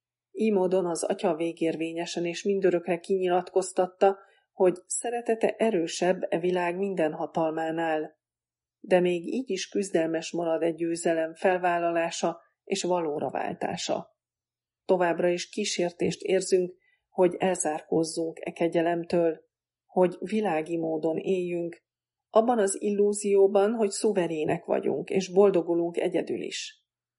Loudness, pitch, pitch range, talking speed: -27 LUFS, 180 Hz, 165-195 Hz, 105 wpm